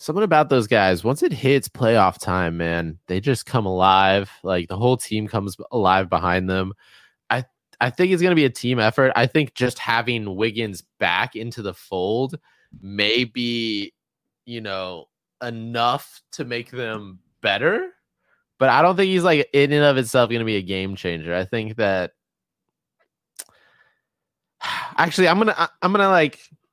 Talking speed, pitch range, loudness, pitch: 175 wpm, 95-140 Hz, -20 LUFS, 115 Hz